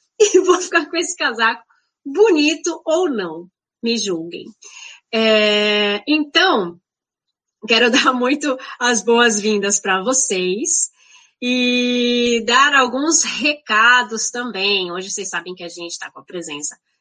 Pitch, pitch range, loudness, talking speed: 245 Hz, 205-300 Hz, -16 LUFS, 125 wpm